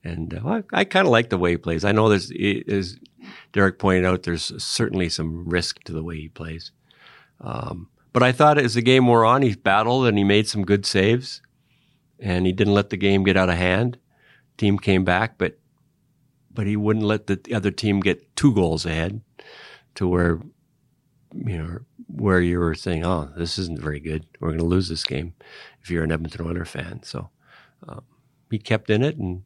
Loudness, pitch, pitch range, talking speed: -21 LUFS, 100 Hz, 85-125 Hz, 205 wpm